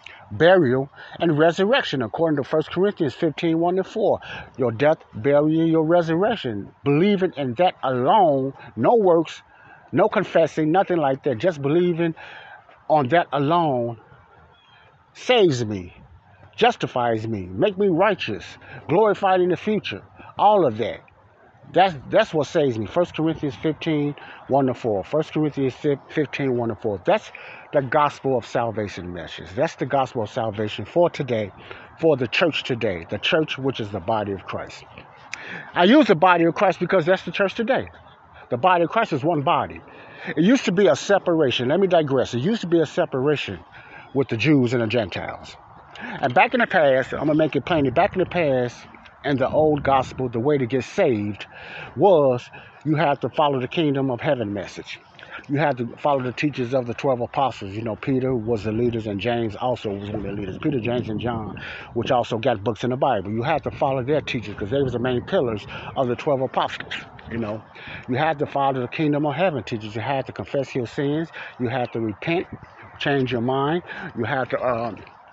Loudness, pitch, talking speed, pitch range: -22 LUFS, 140 Hz, 190 wpm, 120-165 Hz